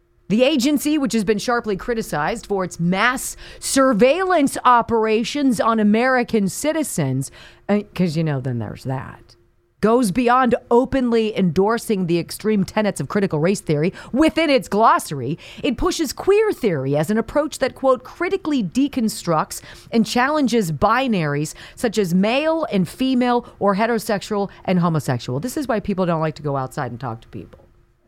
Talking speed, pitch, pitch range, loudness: 150 wpm, 215 Hz, 170-255 Hz, -19 LUFS